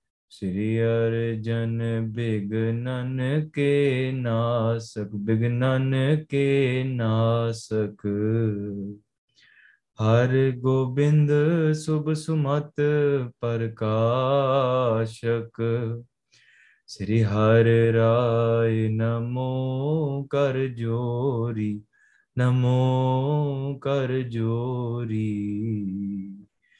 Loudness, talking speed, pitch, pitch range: -24 LUFS, 50 wpm, 115 Hz, 115-130 Hz